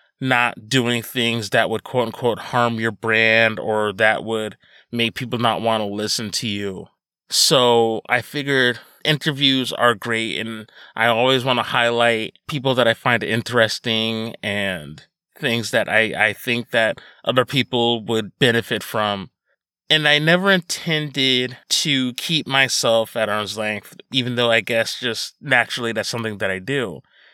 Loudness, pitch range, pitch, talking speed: -19 LUFS, 110-125 Hz, 115 Hz, 155 wpm